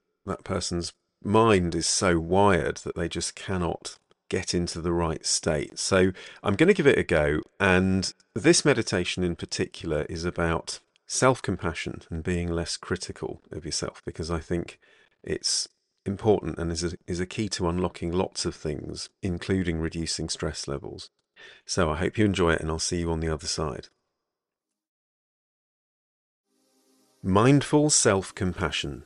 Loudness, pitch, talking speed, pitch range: -26 LUFS, 90 Hz, 155 wpm, 85-100 Hz